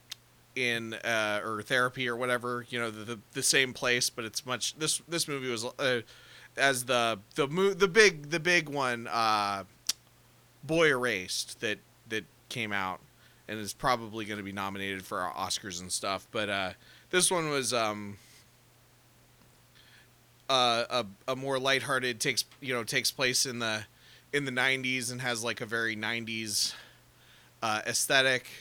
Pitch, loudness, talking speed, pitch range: 125 Hz, -29 LUFS, 165 wpm, 110-130 Hz